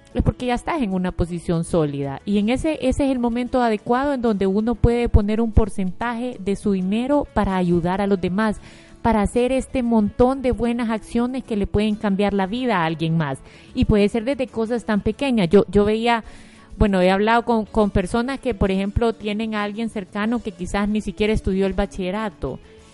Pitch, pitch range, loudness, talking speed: 215 Hz, 200-240 Hz, -21 LUFS, 200 wpm